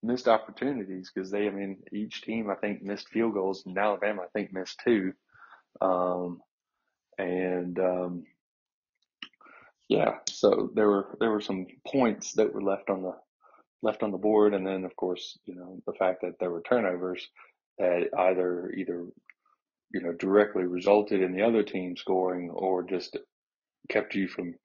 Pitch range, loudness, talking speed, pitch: 90-105 Hz, -29 LUFS, 165 wpm, 95 Hz